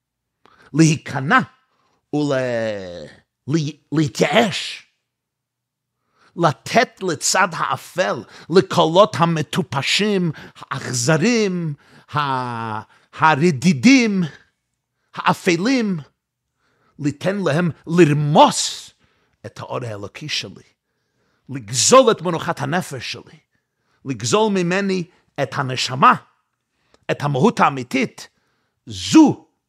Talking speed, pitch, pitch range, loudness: 65 wpm, 155 Hz, 130-180 Hz, -18 LUFS